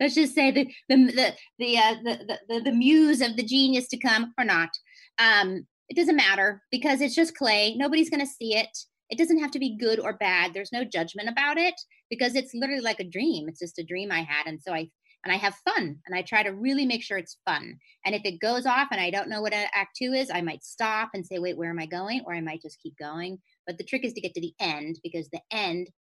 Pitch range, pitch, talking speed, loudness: 180-265 Hz, 220 Hz, 265 wpm, -25 LUFS